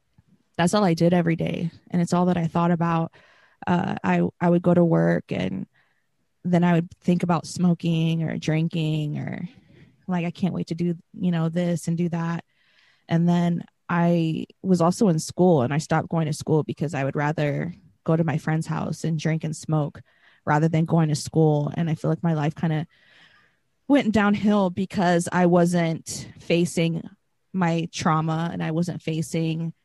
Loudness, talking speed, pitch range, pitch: -23 LUFS, 185 wpm, 160-175 Hz, 170 Hz